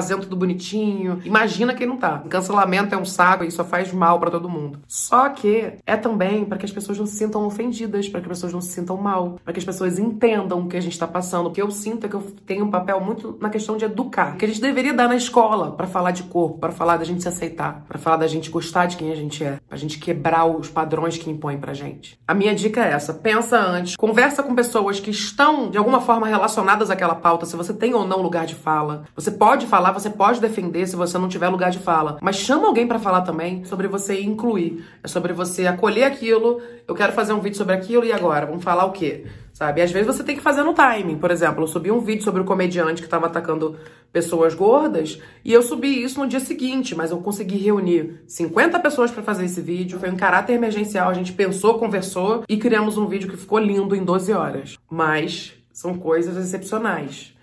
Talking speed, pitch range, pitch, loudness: 240 wpm, 170-215 Hz, 190 Hz, -20 LUFS